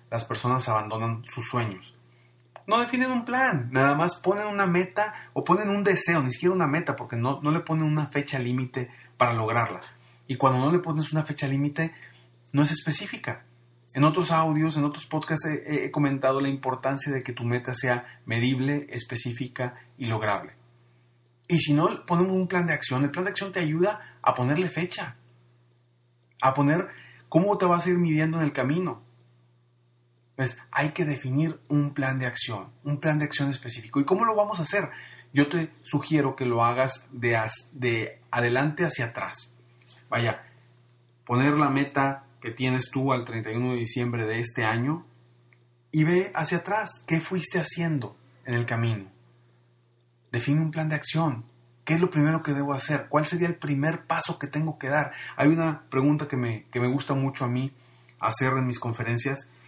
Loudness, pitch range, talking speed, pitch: -26 LUFS, 120-155 Hz, 185 wpm, 135 Hz